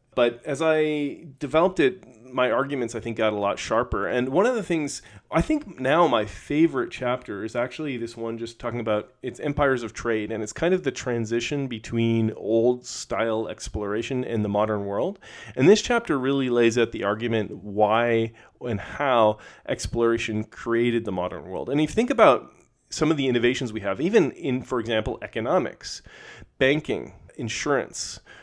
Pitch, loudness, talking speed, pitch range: 120 Hz, -24 LUFS, 175 wpm, 110-140 Hz